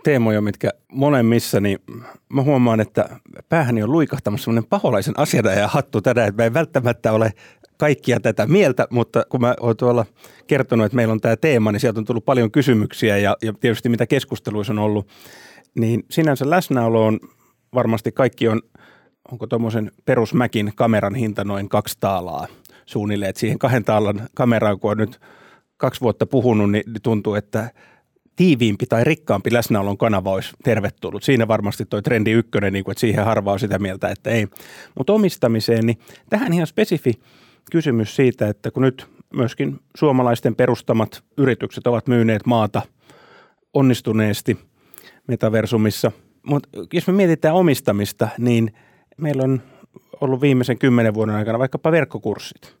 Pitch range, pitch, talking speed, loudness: 110-130 Hz, 115 Hz, 150 wpm, -19 LUFS